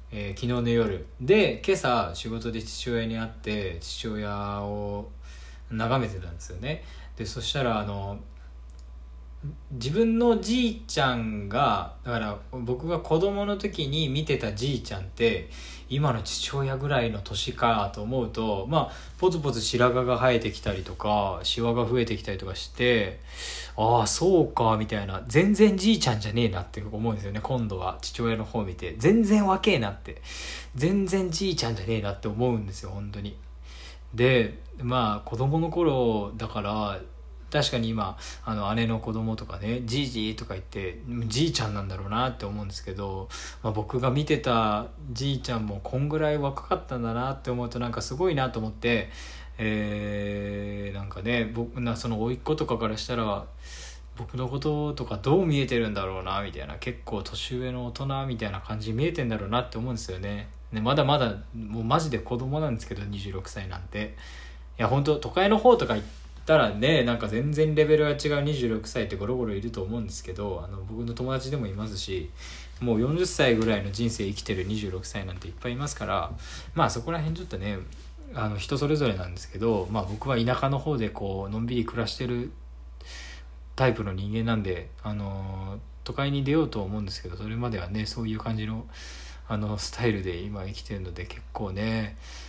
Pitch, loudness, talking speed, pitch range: 110 Hz, -28 LUFS, 345 characters per minute, 100-125 Hz